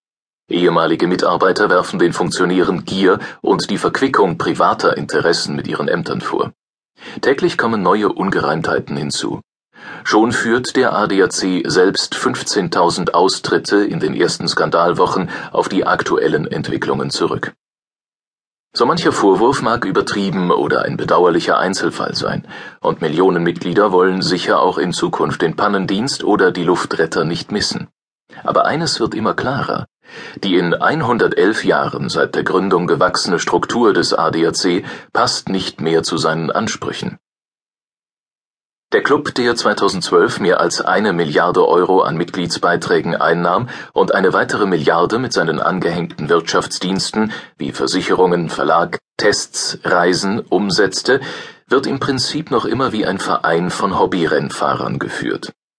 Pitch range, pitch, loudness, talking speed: 85-105 Hz, 90 Hz, -16 LUFS, 130 wpm